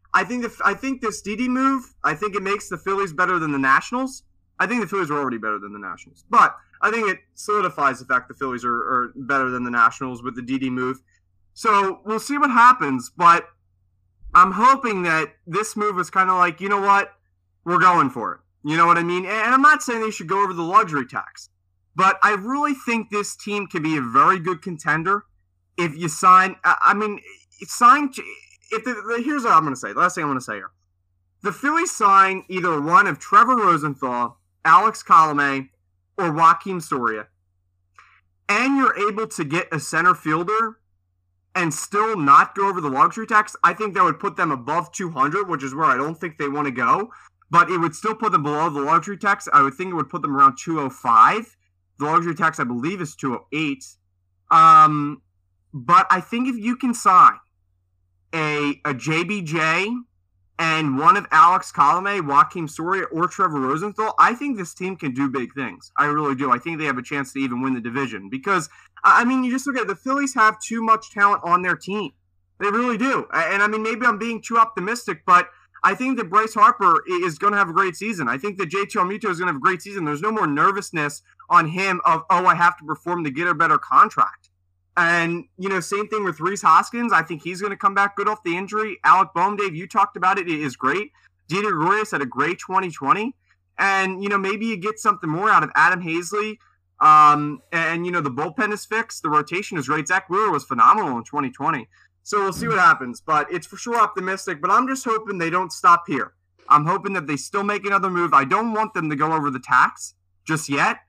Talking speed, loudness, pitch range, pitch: 220 wpm, -19 LUFS, 140-210 Hz, 180 Hz